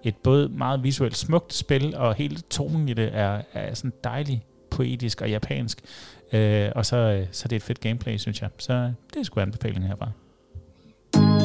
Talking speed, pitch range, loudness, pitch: 185 wpm, 105-130 Hz, -25 LUFS, 115 Hz